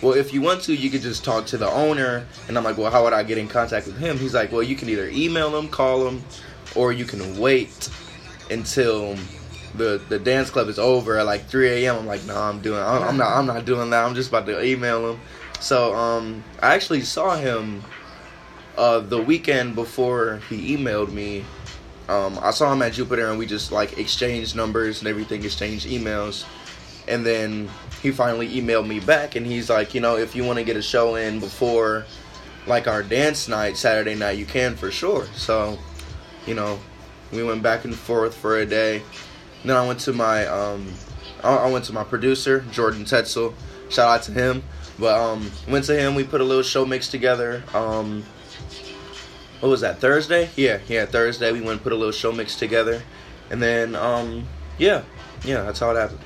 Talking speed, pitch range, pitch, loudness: 205 wpm, 105-125 Hz, 115 Hz, -22 LUFS